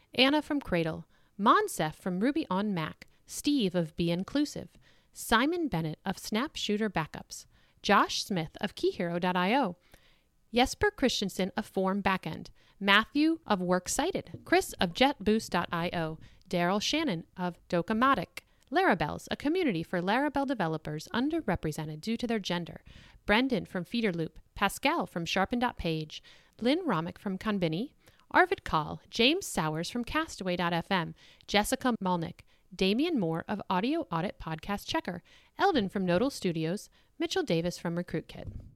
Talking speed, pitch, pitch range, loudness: 125 wpm, 200 Hz, 175-260 Hz, -30 LUFS